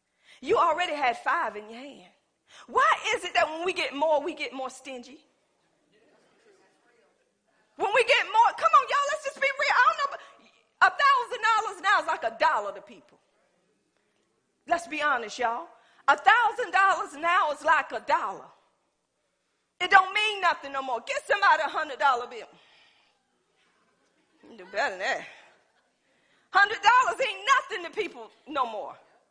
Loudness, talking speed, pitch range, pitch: -25 LUFS, 160 wpm, 275-390 Hz, 320 Hz